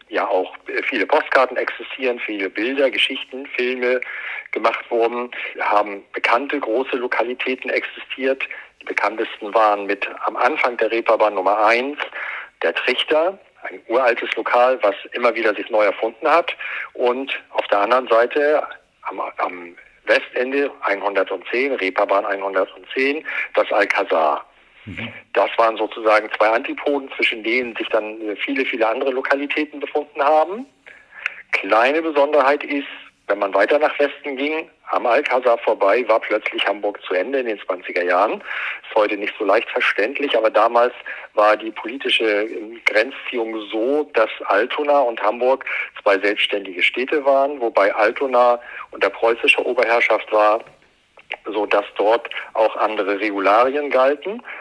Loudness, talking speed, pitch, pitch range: -19 LUFS, 135 wpm, 125 Hz, 105-140 Hz